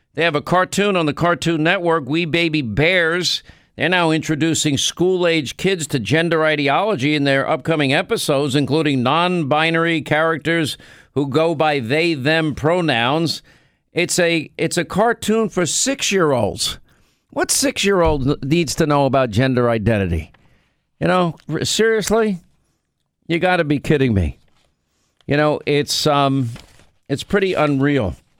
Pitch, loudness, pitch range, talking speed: 160 Hz, -18 LUFS, 140-175 Hz, 130 wpm